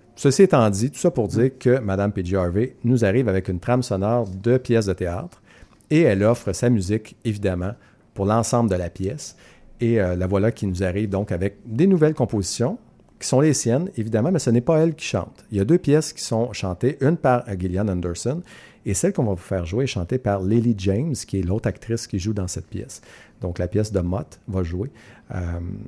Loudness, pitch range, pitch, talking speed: -22 LUFS, 95-125 Hz, 110 Hz, 225 wpm